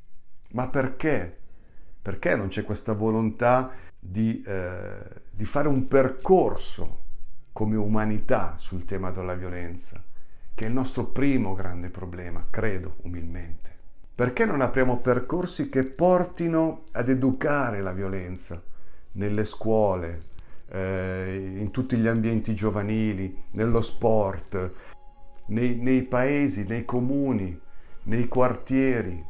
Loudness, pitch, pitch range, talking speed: -26 LUFS, 105 Hz, 90-125 Hz, 115 wpm